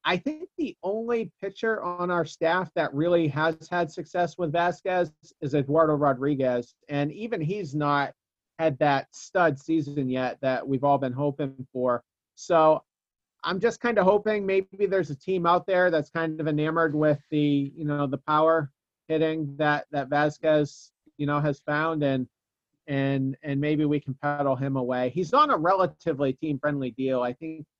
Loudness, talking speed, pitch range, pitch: -26 LUFS, 175 wpm, 140-175 Hz, 155 Hz